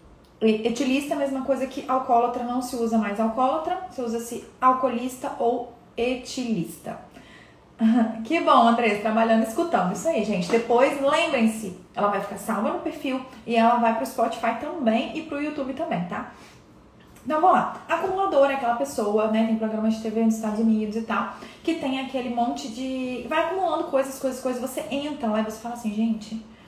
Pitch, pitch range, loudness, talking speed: 240 Hz, 225-275 Hz, -24 LUFS, 180 wpm